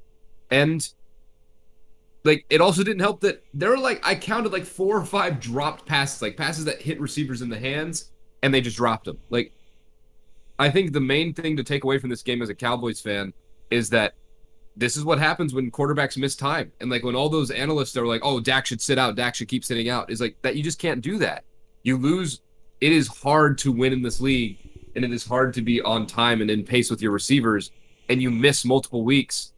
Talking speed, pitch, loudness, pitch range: 225 wpm, 130 Hz, -23 LUFS, 115-150 Hz